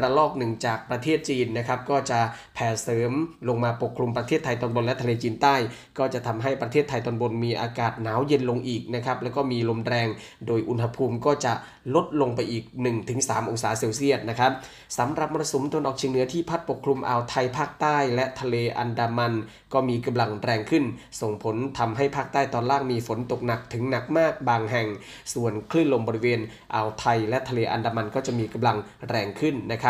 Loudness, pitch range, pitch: -26 LUFS, 115-135 Hz, 120 Hz